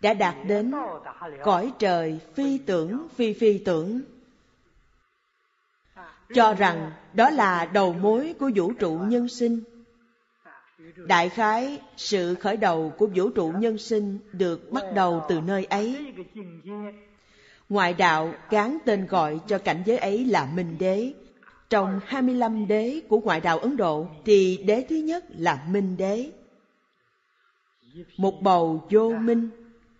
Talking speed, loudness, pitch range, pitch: 135 wpm, -24 LUFS, 185-235 Hz, 210 Hz